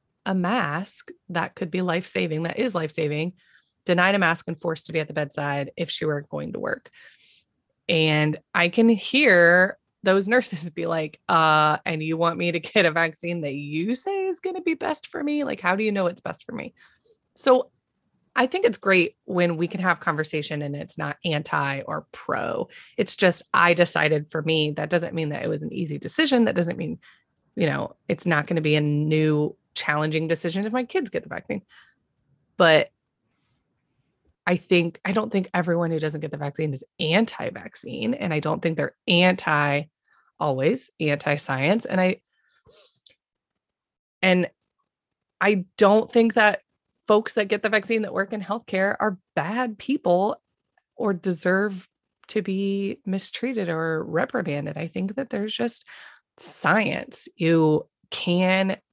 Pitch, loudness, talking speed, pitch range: 175 Hz, -23 LUFS, 170 wpm, 160-210 Hz